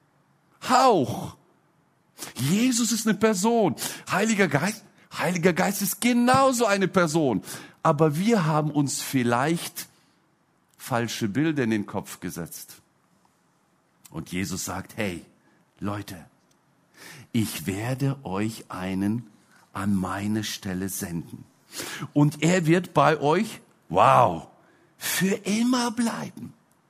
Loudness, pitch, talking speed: -24 LUFS, 155 Hz, 105 wpm